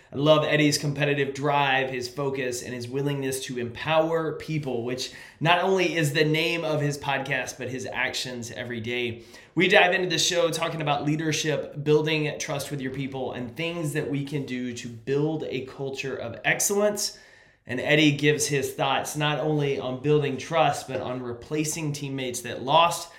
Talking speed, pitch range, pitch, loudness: 175 wpm, 130-155 Hz, 140 Hz, -25 LUFS